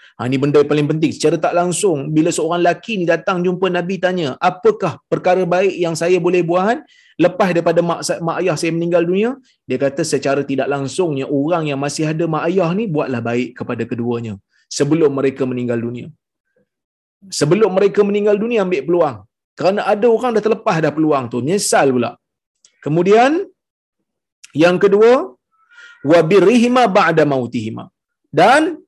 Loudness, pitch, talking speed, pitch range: -16 LUFS, 170 Hz, 155 wpm, 145-200 Hz